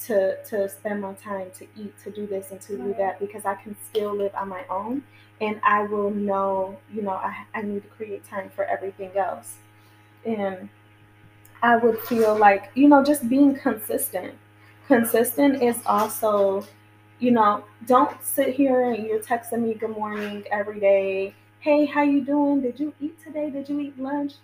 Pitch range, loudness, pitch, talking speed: 195-250 Hz, -23 LUFS, 210 Hz, 185 wpm